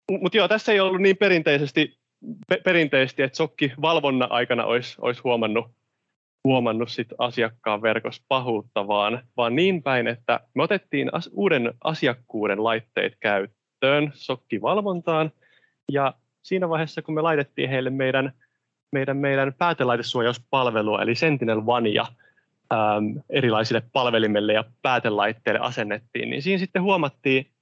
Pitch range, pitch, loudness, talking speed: 120-160 Hz, 135 Hz, -23 LUFS, 120 wpm